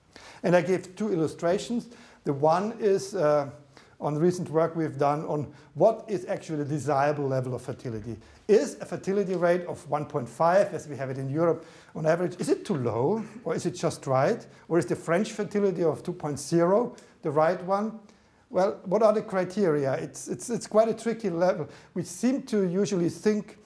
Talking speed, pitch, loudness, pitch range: 185 wpm, 170 Hz, -27 LUFS, 150-200 Hz